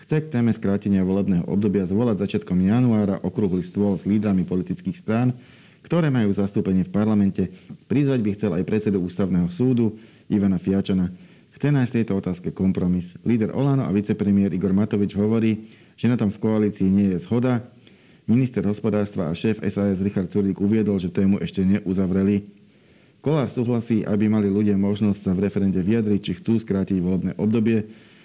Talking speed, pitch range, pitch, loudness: 160 wpm, 95-115 Hz, 100 Hz, -22 LUFS